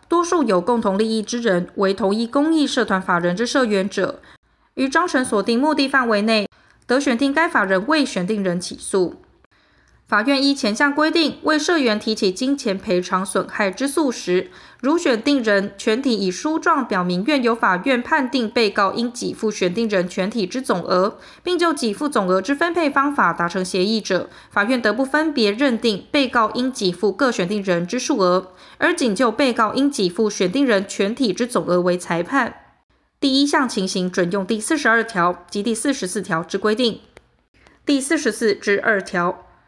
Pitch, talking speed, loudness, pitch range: 225 Hz, 270 characters per minute, -19 LUFS, 195-275 Hz